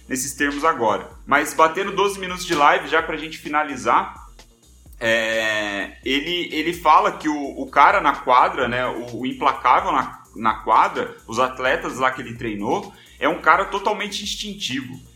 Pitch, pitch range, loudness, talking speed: 150 Hz, 130-175 Hz, -20 LUFS, 165 wpm